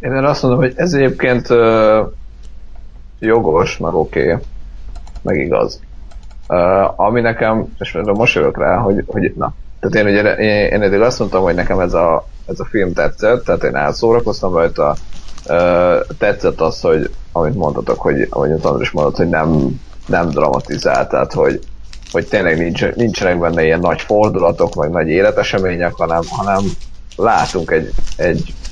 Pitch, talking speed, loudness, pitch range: 95 Hz, 155 wpm, -15 LUFS, 80-115 Hz